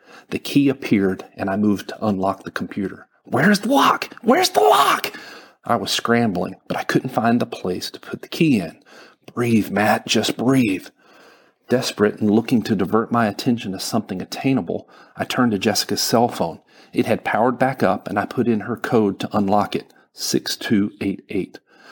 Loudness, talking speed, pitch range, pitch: -20 LUFS, 180 wpm, 100-125 Hz, 110 Hz